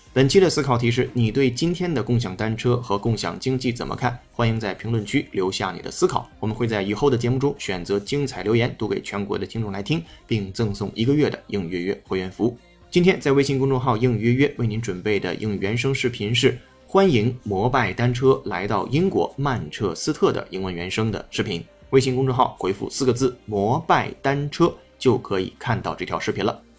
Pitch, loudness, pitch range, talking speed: 120 Hz, -22 LUFS, 105-135 Hz, 325 characters per minute